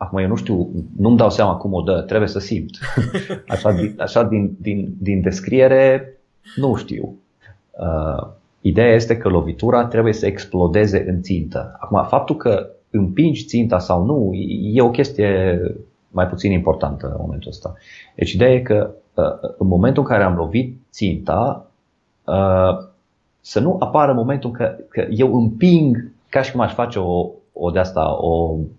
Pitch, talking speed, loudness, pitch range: 100 Hz, 165 wpm, -18 LUFS, 90-120 Hz